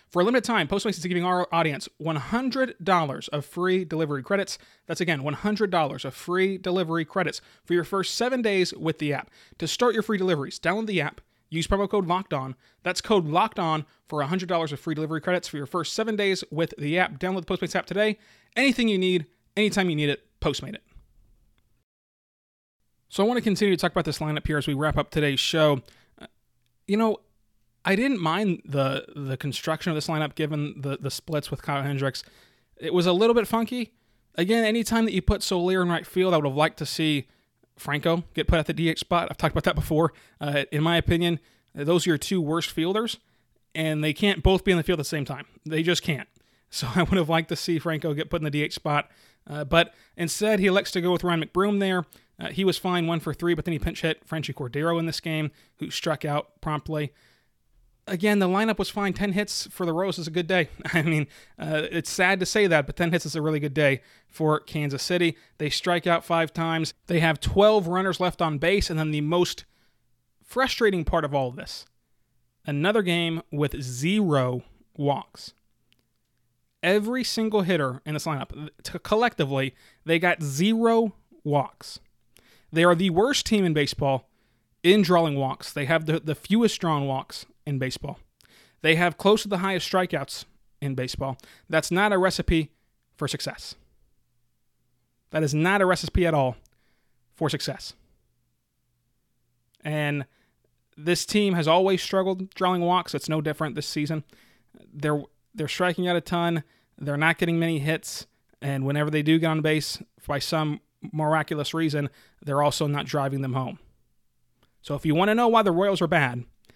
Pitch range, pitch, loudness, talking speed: 145-185 Hz, 165 Hz, -25 LUFS, 195 wpm